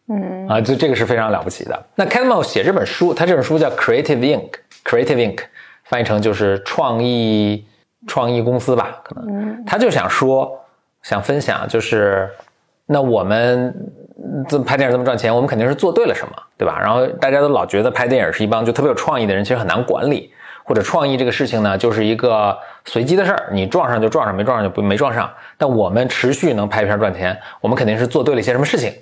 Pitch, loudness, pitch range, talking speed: 125 Hz, -17 LUFS, 110-160 Hz, 370 characters per minute